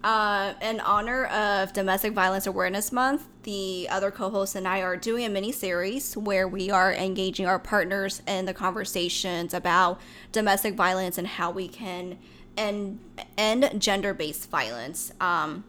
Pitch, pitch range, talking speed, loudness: 195 Hz, 185-210 Hz, 155 wpm, -26 LUFS